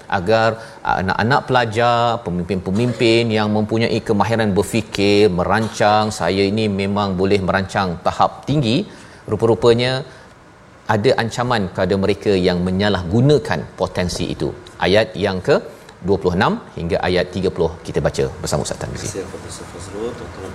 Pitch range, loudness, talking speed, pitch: 95-115 Hz, -18 LUFS, 105 wpm, 105 Hz